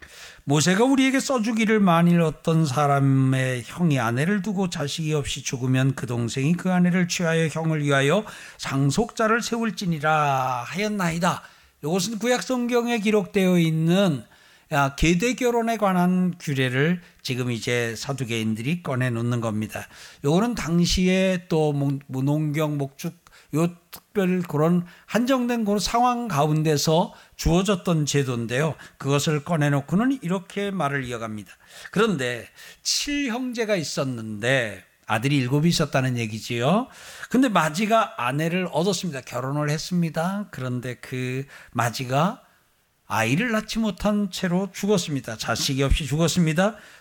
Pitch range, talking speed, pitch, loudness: 135-200 Hz, 295 characters per minute, 160 Hz, -23 LUFS